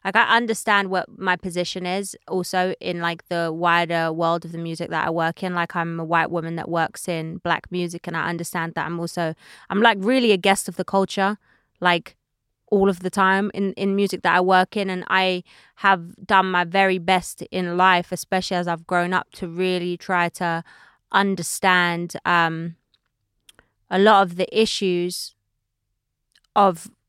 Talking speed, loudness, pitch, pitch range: 180 wpm, -21 LUFS, 180 Hz, 170-195 Hz